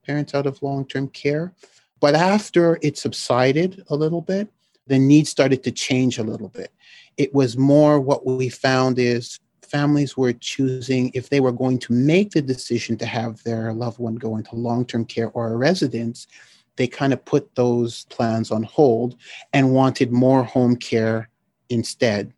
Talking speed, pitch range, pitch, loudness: 170 wpm, 120-145 Hz, 130 Hz, -20 LUFS